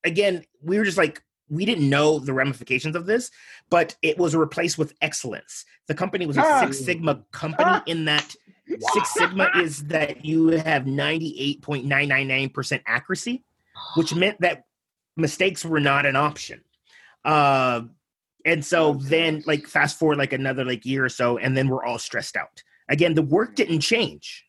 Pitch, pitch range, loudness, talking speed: 155 Hz, 140-170 Hz, -22 LUFS, 180 wpm